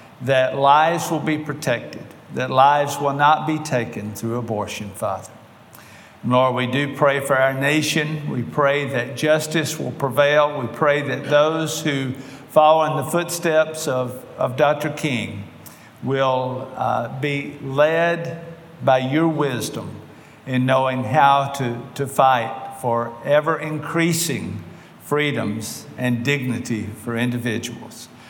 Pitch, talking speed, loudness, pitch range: 140 Hz, 130 wpm, -20 LUFS, 125-155 Hz